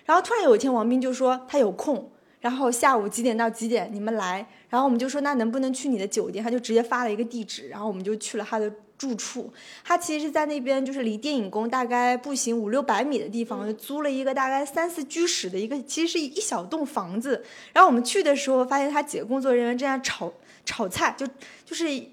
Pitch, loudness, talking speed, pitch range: 255 Hz, -25 LUFS, 360 characters per minute, 225-285 Hz